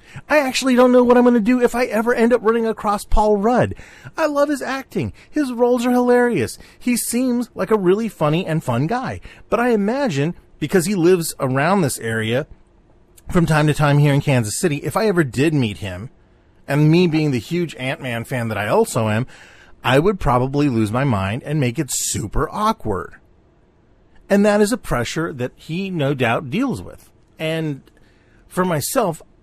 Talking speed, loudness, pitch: 195 wpm, -18 LUFS, 165 Hz